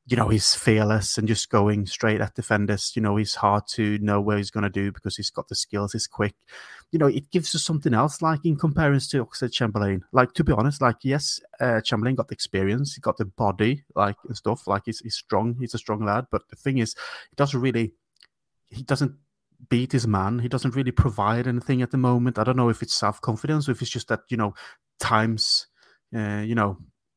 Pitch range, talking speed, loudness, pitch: 105-130 Hz, 235 wpm, -24 LUFS, 115 Hz